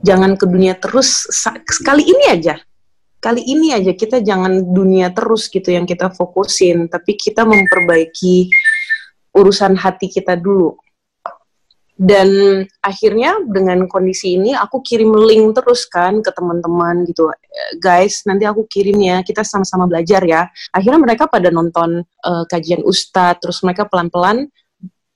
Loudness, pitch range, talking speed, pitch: -13 LUFS, 180-220 Hz, 135 wpm, 190 Hz